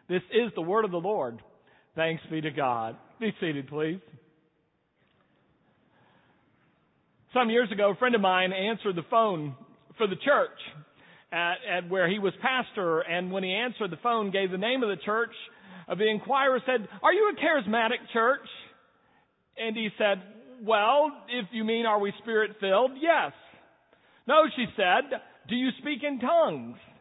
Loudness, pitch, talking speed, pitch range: -27 LUFS, 220 Hz, 160 wpm, 185-250 Hz